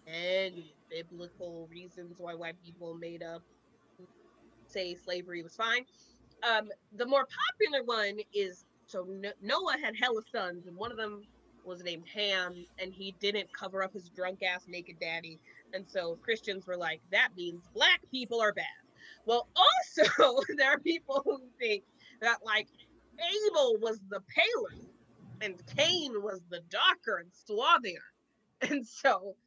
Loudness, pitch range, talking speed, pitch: -31 LUFS, 180-255 Hz, 150 wpm, 205 Hz